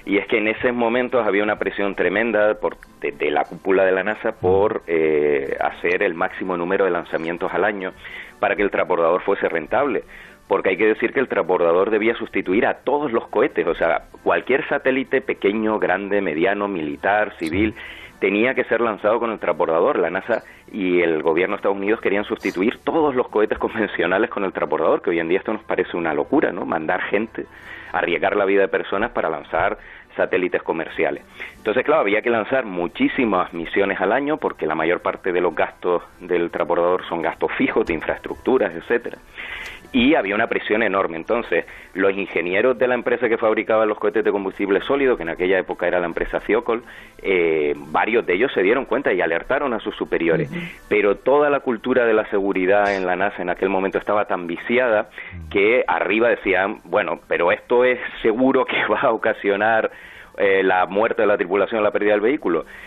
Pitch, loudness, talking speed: 125 Hz, -20 LUFS, 195 wpm